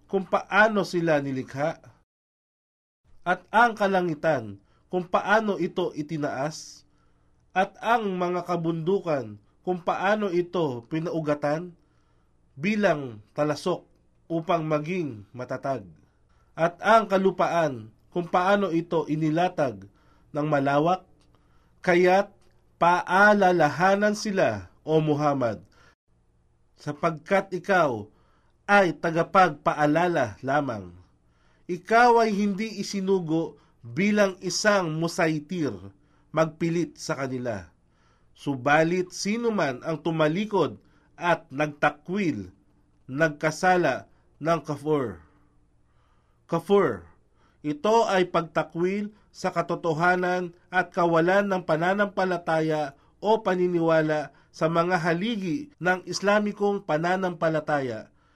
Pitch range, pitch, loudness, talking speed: 145-185 Hz, 170 Hz, -25 LUFS, 85 wpm